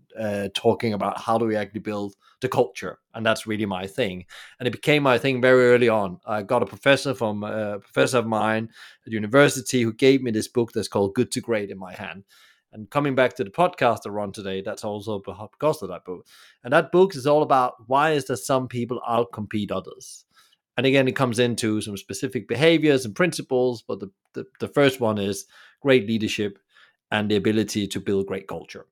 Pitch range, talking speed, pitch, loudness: 105-130 Hz, 210 wpm, 115 Hz, -23 LUFS